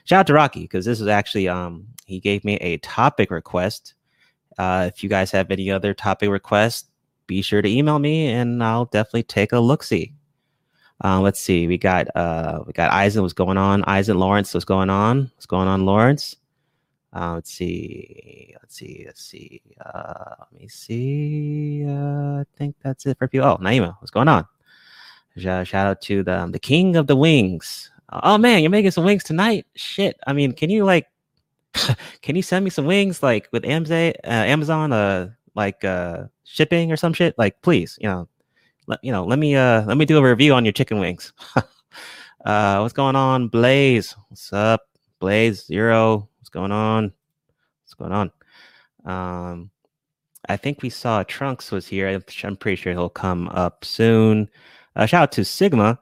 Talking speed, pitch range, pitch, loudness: 185 wpm, 95-145 Hz, 110 Hz, -19 LUFS